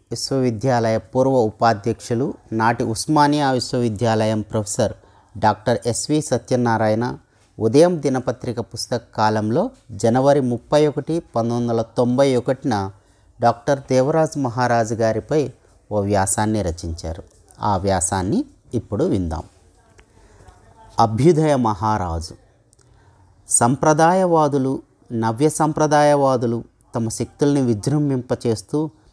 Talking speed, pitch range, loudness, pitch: 80 wpm, 110-135 Hz, -19 LUFS, 115 Hz